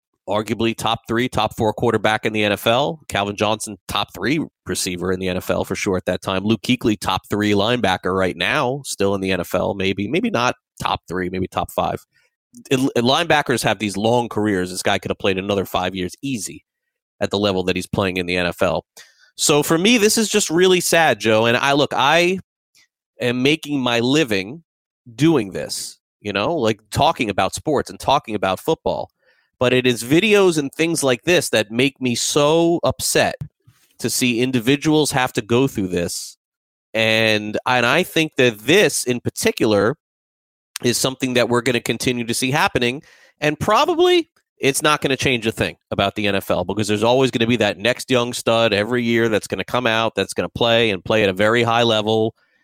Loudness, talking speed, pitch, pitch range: -19 LUFS, 195 wpm, 120 Hz, 105-135 Hz